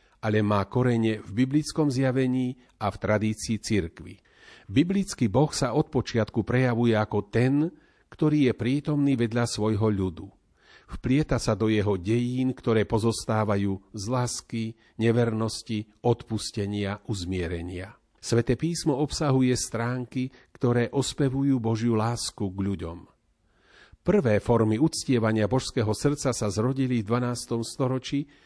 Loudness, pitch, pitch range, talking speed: -26 LUFS, 115 Hz, 110-130 Hz, 120 wpm